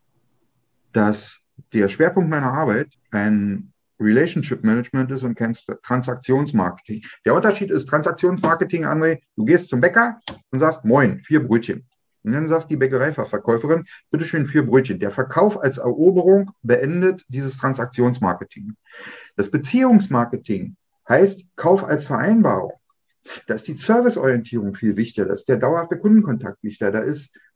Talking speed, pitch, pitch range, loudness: 135 wpm, 135 Hz, 120-175 Hz, -19 LUFS